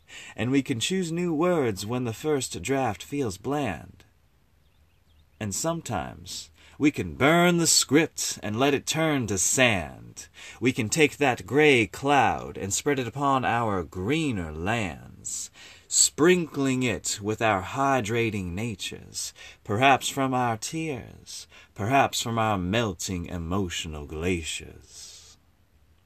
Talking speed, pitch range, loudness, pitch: 125 wpm, 90-135 Hz, -25 LUFS, 110 Hz